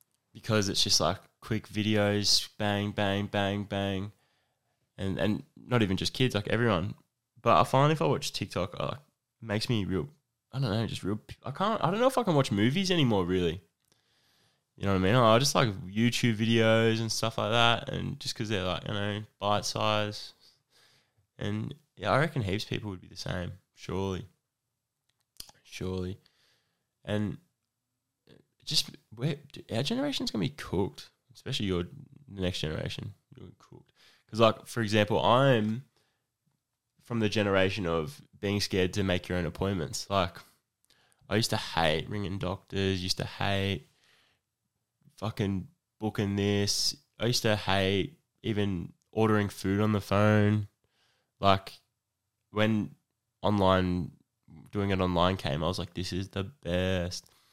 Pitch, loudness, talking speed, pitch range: 105 Hz, -29 LUFS, 155 wpm, 95-120 Hz